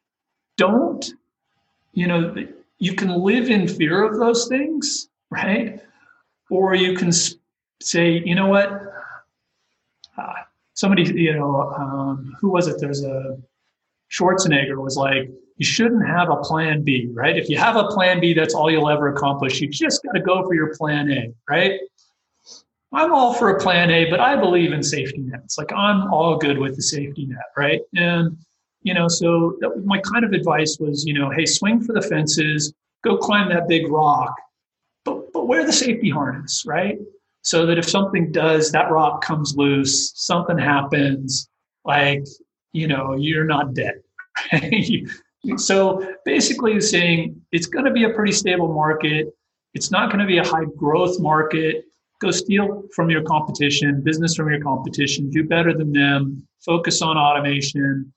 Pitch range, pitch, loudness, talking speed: 145-195 Hz, 165 Hz, -19 LUFS, 170 wpm